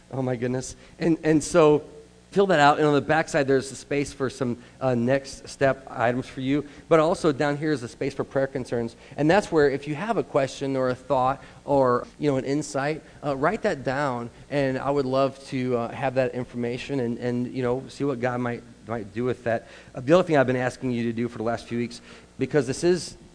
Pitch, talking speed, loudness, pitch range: 135 Hz, 240 wpm, -25 LUFS, 125-145 Hz